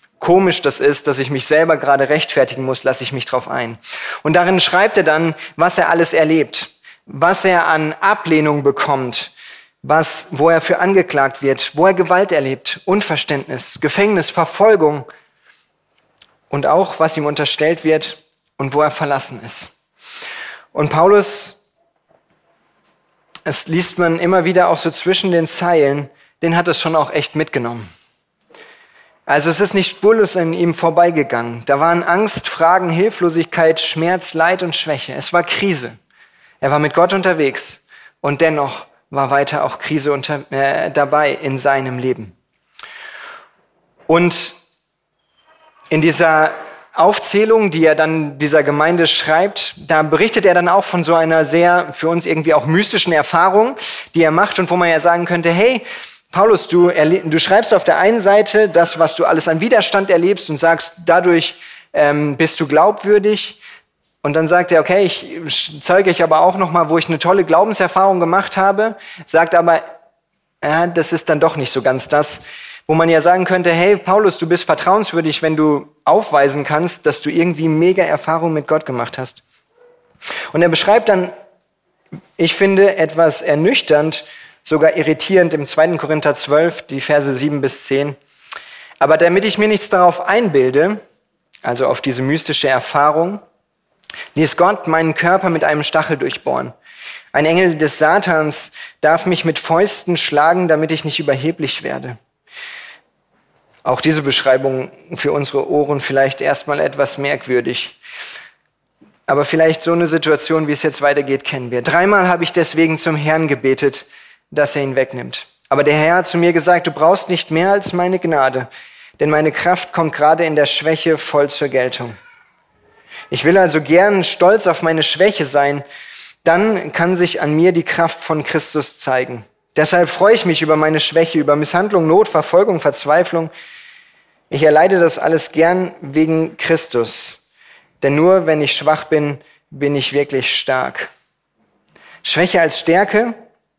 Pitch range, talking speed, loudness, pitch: 150-180 Hz, 160 wpm, -14 LUFS, 160 Hz